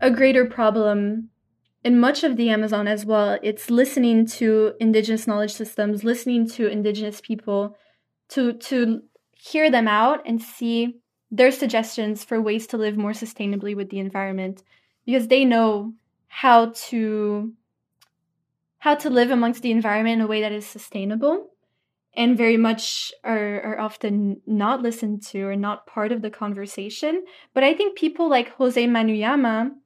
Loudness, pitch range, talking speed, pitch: -21 LUFS, 210-245 Hz, 155 wpm, 225 Hz